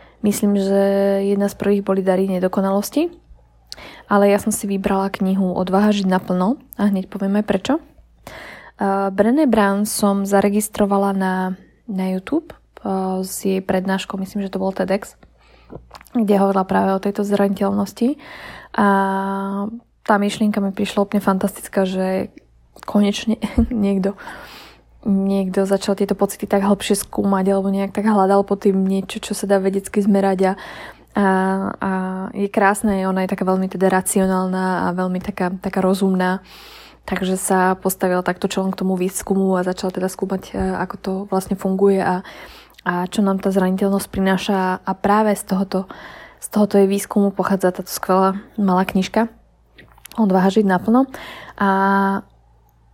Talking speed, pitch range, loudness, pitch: 145 wpm, 190-205 Hz, -19 LUFS, 195 Hz